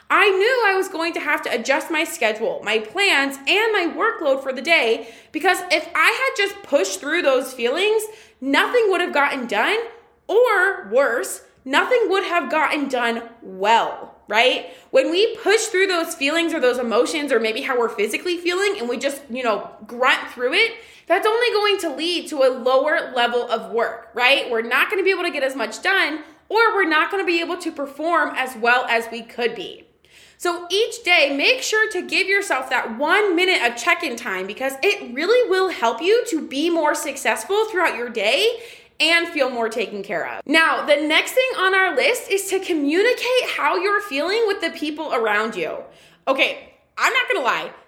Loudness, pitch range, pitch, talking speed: -19 LUFS, 260-400 Hz, 330 Hz, 200 wpm